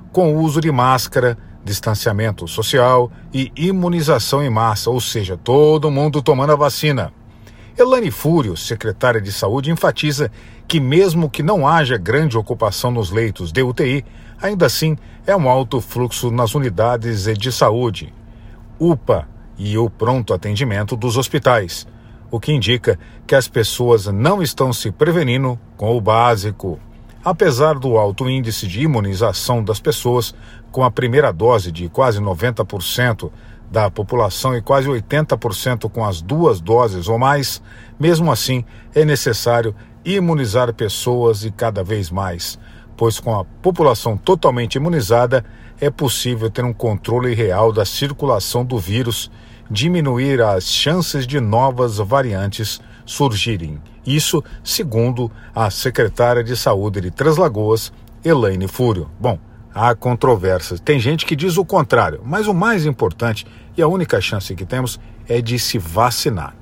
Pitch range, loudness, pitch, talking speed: 110-140 Hz, -17 LUFS, 120 Hz, 140 wpm